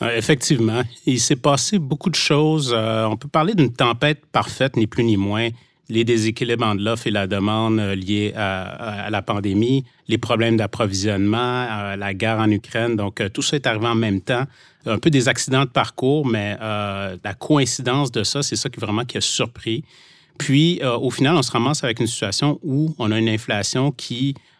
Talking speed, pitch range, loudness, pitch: 195 wpm, 110-140 Hz, -20 LUFS, 115 Hz